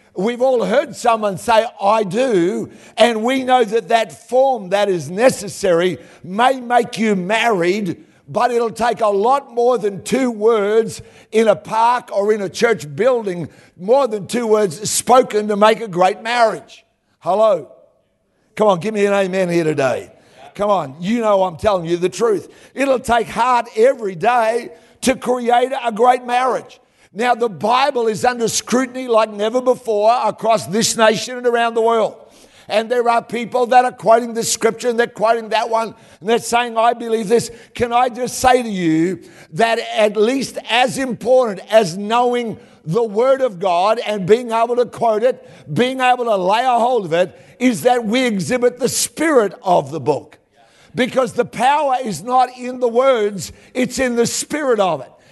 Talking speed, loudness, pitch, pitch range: 180 wpm, -17 LUFS, 230 Hz, 210-245 Hz